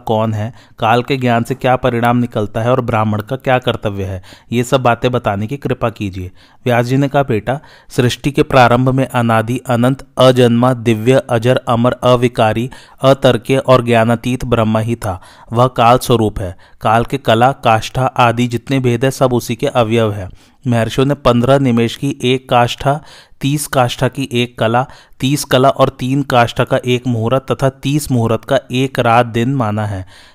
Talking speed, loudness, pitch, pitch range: 180 wpm, -14 LUFS, 125 Hz, 115-130 Hz